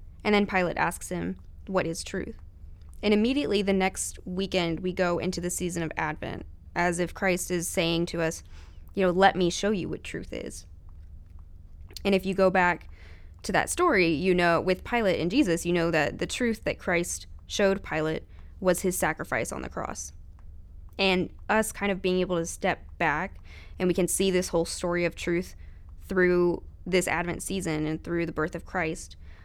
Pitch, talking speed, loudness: 175 Hz, 190 wpm, -27 LUFS